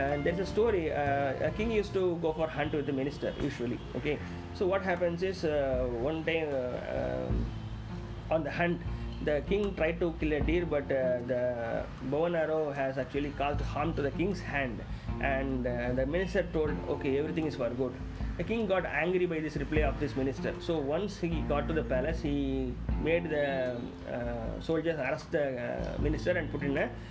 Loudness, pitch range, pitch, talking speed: -32 LUFS, 125-165 Hz, 145 Hz, 200 wpm